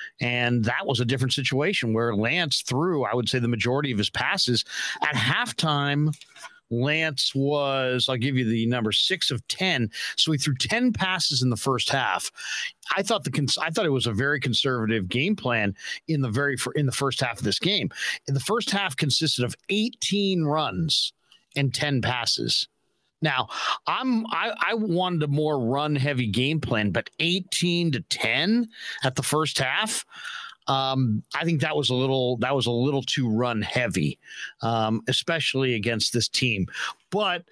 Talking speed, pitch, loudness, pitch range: 180 wpm, 135 Hz, -24 LUFS, 125-160 Hz